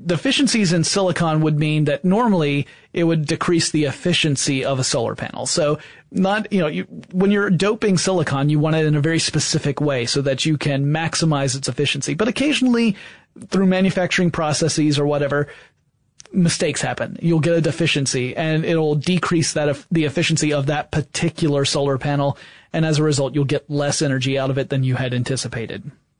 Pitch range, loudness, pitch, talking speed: 145-175 Hz, -19 LUFS, 155 Hz, 180 wpm